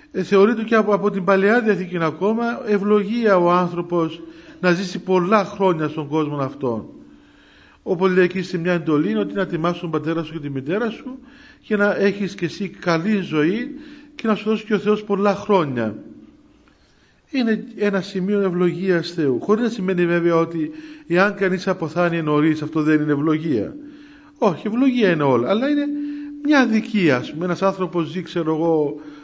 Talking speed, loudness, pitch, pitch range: 170 wpm, -20 LUFS, 190 Hz, 165-215 Hz